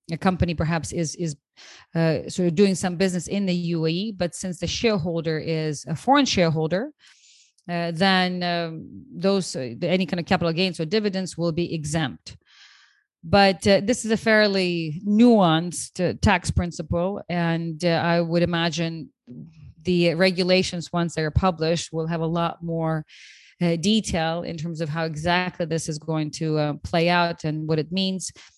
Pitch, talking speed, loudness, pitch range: 170 Hz, 170 wpm, -23 LUFS, 165-185 Hz